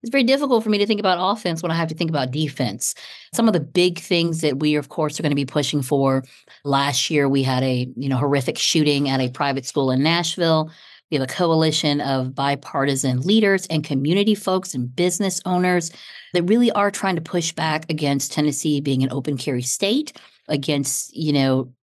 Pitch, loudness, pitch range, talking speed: 150 Hz, -20 LUFS, 140-180 Hz, 210 wpm